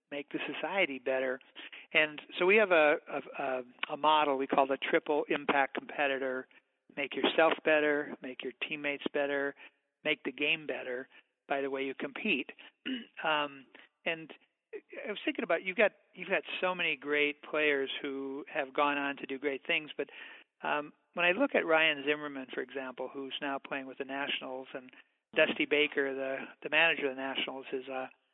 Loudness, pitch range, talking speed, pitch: -32 LUFS, 135-155 Hz, 175 wpm, 145 Hz